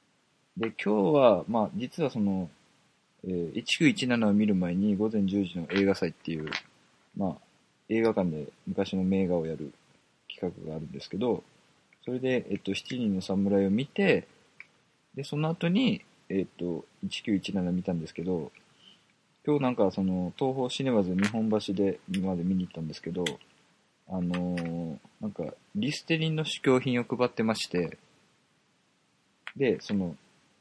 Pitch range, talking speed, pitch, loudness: 90-125 Hz, 270 characters per minute, 100 Hz, -29 LUFS